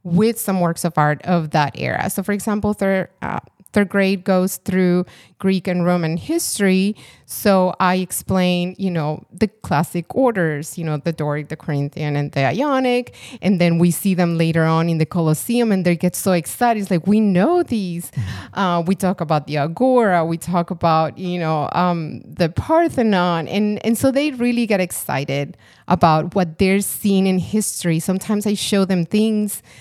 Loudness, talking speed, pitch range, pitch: -19 LUFS, 180 wpm, 165-205 Hz, 185 Hz